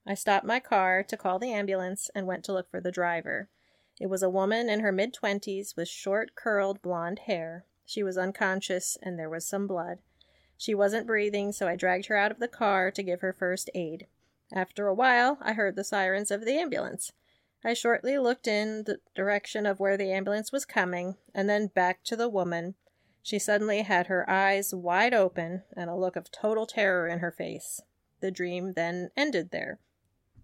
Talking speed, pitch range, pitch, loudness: 200 wpm, 185-210 Hz, 195 Hz, -29 LUFS